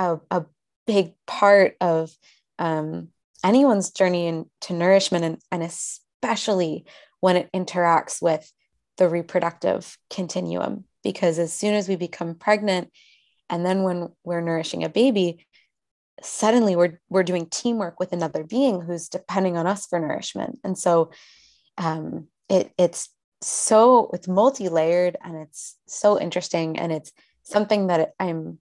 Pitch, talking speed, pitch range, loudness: 180 Hz, 140 wpm, 170-195 Hz, -22 LUFS